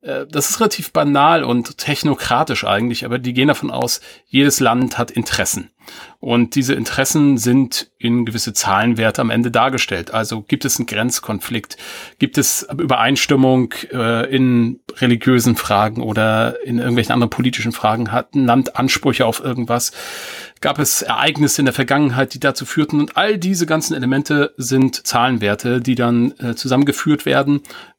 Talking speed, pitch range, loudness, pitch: 150 wpm, 120-140 Hz, -16 LUFS, 125 Hz